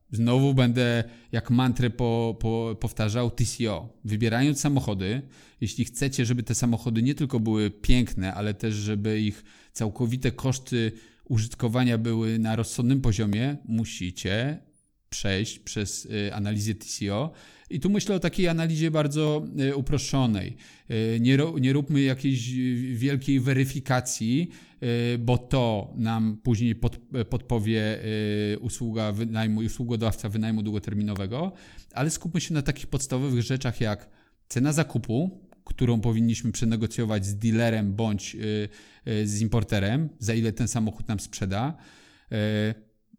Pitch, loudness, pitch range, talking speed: 115 Hz, -27 LUFS, 110-130 Hz, 130 wpm